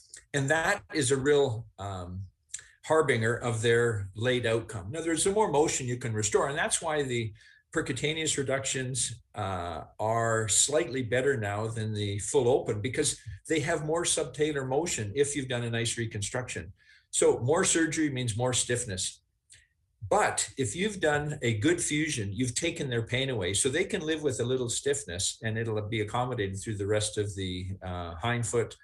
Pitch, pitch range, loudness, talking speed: 120 Hz, 105-145 Hz, -29 LUFS, 175 wpm